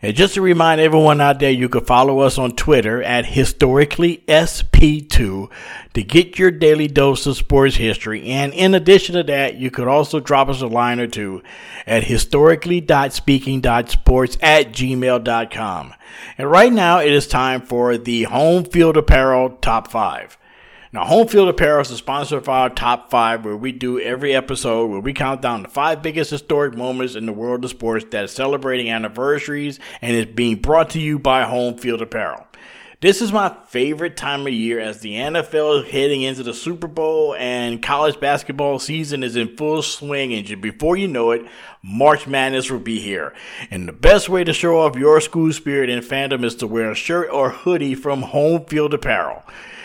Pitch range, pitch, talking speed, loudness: 120-155 Hz, 135 Hz, 185 wpm, -17 LUFS